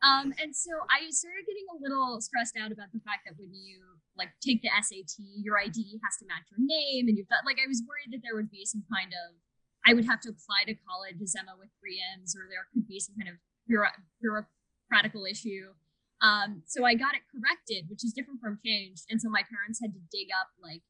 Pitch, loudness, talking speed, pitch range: 215 Hz, -30 LUFS, 235 wpm, 190-245 Hz